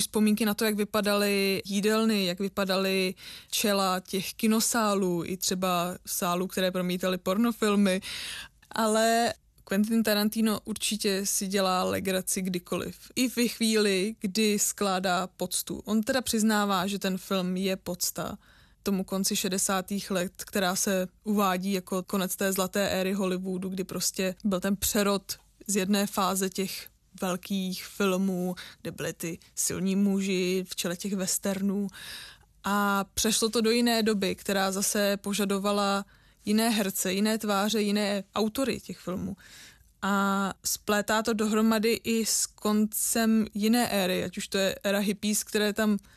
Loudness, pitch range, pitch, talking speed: -27 LUFS, 190-215 Hz, 200 Hz, 140 wpm